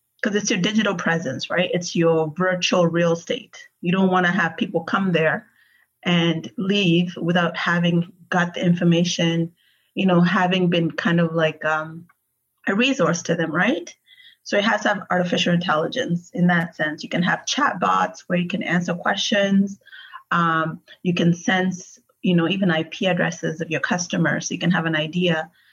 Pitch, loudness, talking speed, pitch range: 175 Hz, -21 LUFS, 180 wpm, 170-190 Hz